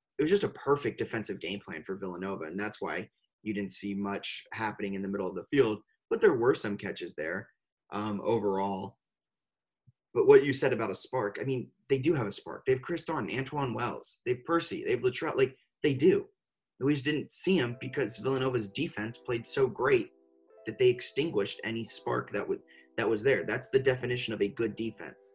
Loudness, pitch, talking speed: -31 LUFS, 125 Hz, 210 wpm